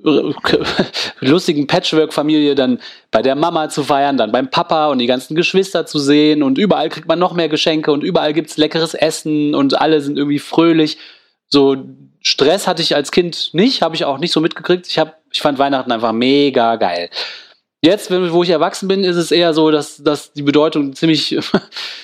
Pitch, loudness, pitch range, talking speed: 155 Hz, -15 LUFS, 145-165 Hz, 190 wpm